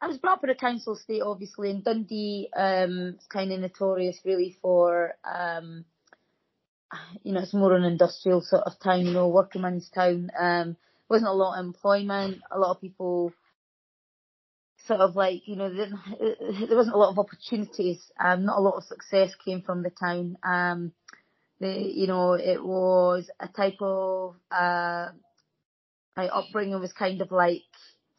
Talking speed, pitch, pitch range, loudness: 170 wpm, 185 Hz, 180-200 Hz, -26 LUFS